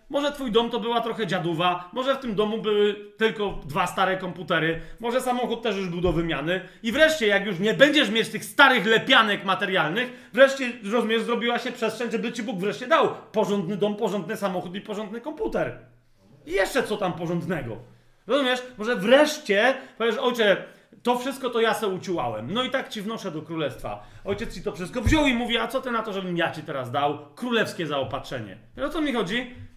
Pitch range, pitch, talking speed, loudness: 185-245 Hz, 215 Hz, 195 wpm, -24 LUFS